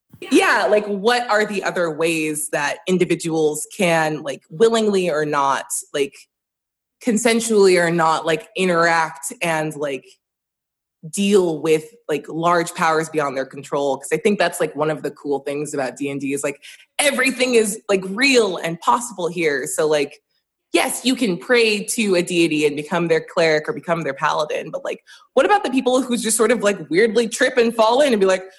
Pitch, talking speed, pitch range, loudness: 175 Hz, 185 wpm, 155-225 Hz, -19 LUFS